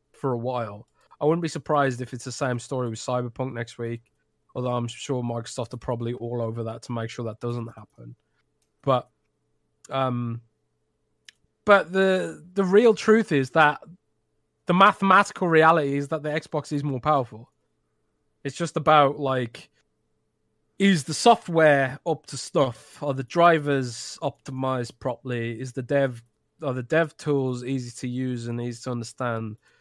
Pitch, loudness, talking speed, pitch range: 130 Hz, -24 LUFS, 160 wpm, 120-150 Hz